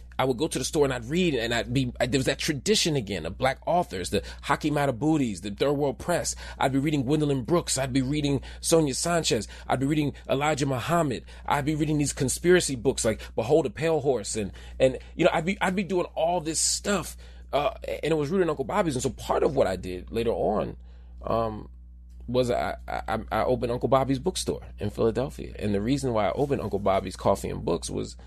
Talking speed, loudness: 225 wpm, -26 LUFS